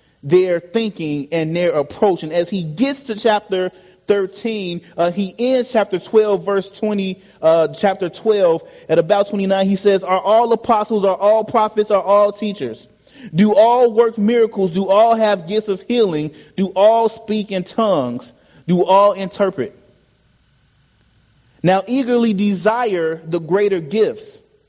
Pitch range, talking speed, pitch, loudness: 180-220 Hz, 145 wpm, 200 Hz, -17 LUFS